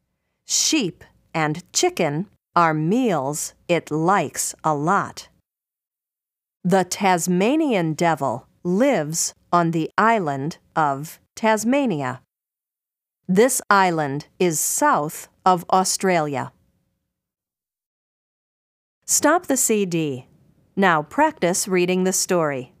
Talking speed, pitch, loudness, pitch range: 85 wpm, 180 Hz, -20 LUFS, 155-200 Hz